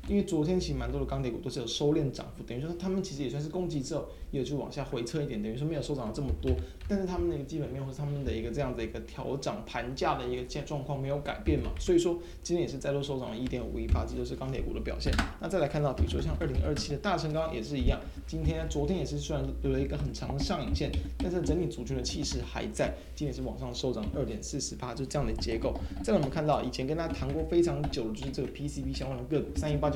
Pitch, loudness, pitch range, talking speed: 140 Hz, -33 LUFS, 115-155 Hz, 430 characters per minute